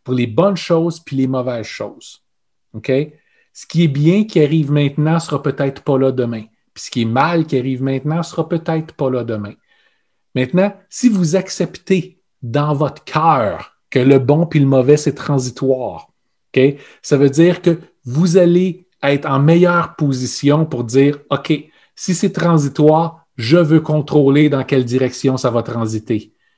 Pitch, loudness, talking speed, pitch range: 150 Hz, -16 LUFS, 175 wpm, 135-170 Hz